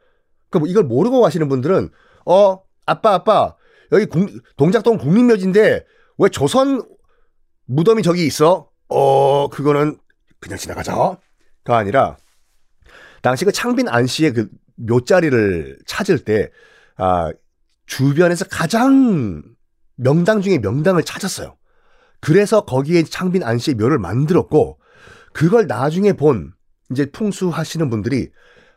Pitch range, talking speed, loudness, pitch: 135-205 Hz, 250 characters per minute, -16 LUFS, 160 Hz